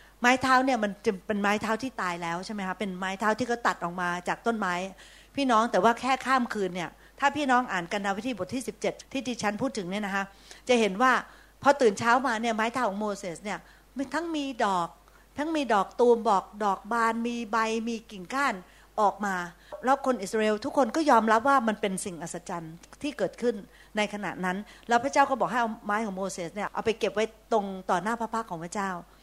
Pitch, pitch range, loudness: 220 Hz, 195-245 Hz, -28 LUFS